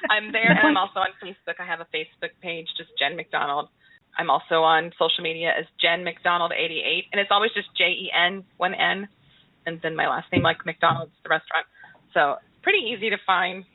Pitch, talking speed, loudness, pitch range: 175 Hz, 210 wpm, -23 LUFS, 165-200 Hz